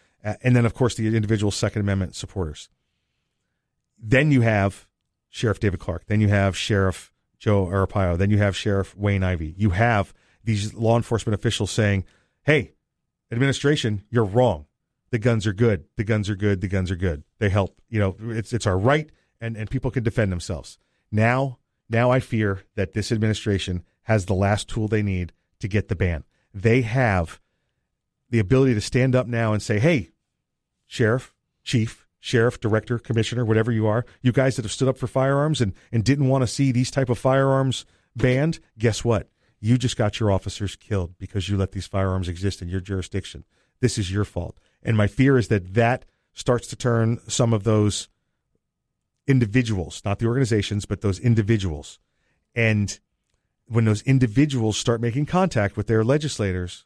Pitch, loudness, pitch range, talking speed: 110 Hz, -23 LUFS, 100-120 Hz, 180 wpm